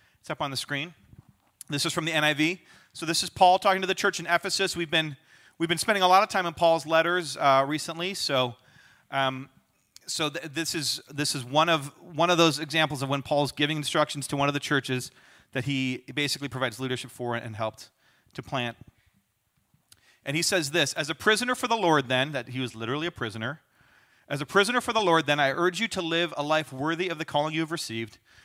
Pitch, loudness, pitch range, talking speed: 150 Hz, -26 LUFS, 135-170 Hz, 220 wpm